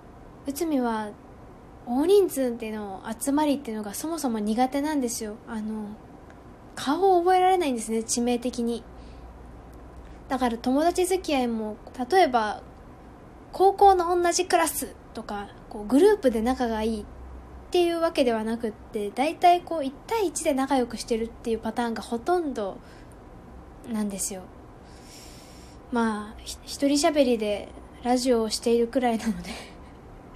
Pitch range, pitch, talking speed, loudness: 215-290 Hz, 240 Hz, 295 characters per minute, -25 LUFS